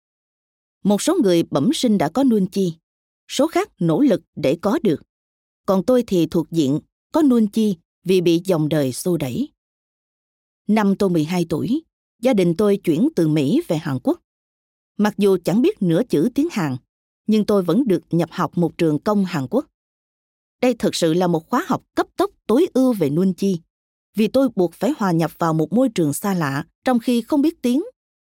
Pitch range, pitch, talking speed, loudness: 170-255 Hz, 195 Hz, 195 wpm, -20 LUFS